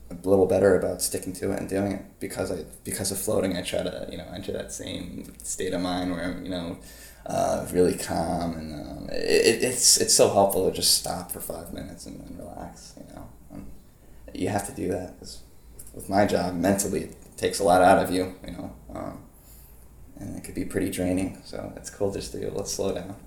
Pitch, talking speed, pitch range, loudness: 90 Hz, 225 wpm, 85-95 Hz, -25 LUFS